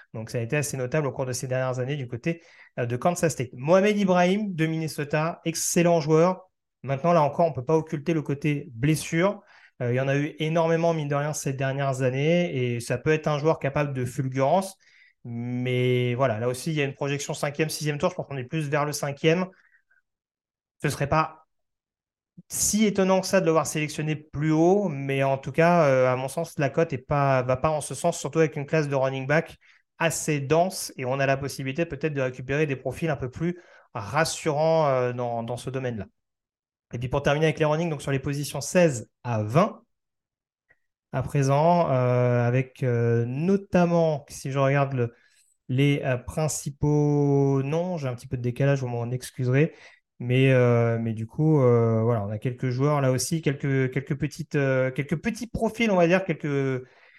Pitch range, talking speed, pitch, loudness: 130-160 Hz, 200 wpm, 145 Hz, -25 LUFS